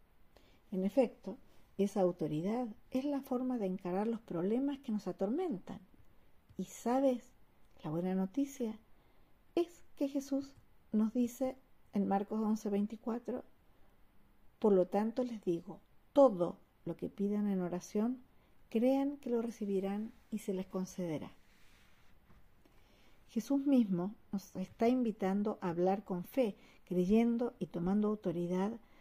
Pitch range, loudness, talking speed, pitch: 190-245 Hz, -36 LUFS, 120 wpm, 215 Hz